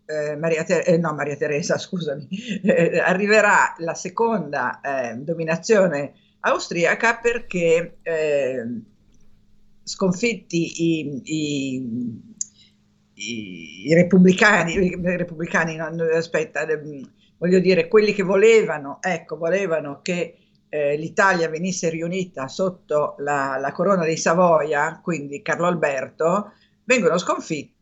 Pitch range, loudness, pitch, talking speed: 150-190 Hz, -21 LUFS, 165 Hz, 100 wpm